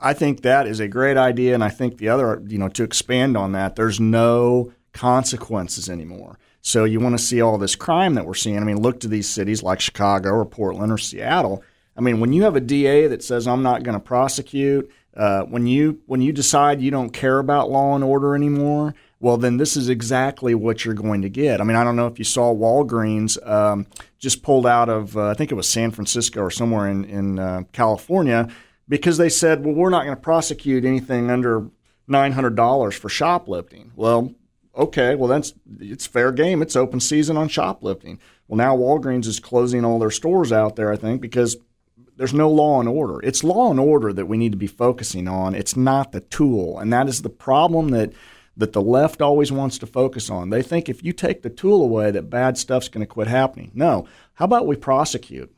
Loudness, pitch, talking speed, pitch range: -19 LUFS, 120 Hz, 220 wpm, 110-140 Hz